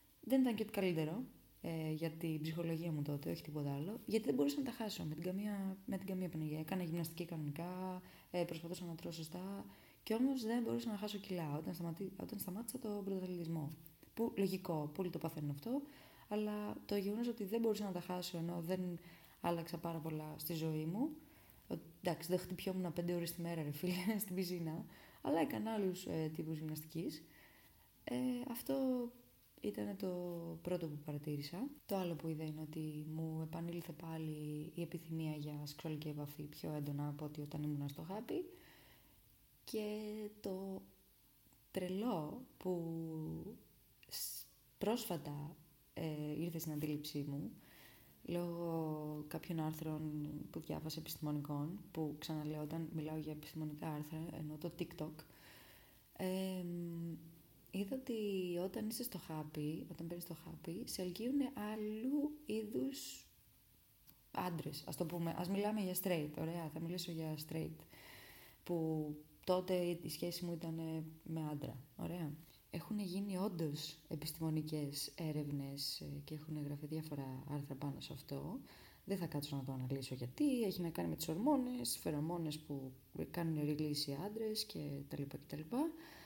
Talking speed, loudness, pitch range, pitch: 150 wpm, -43 LUFS, 150-190 Hz, 165 Hz